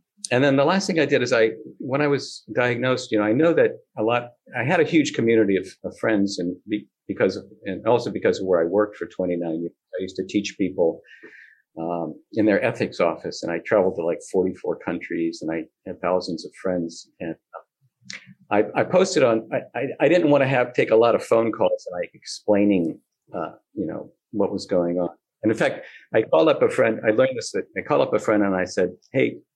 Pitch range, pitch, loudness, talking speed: 90-150 Hz, 110 Hz, -22 LUFS, 230 wpm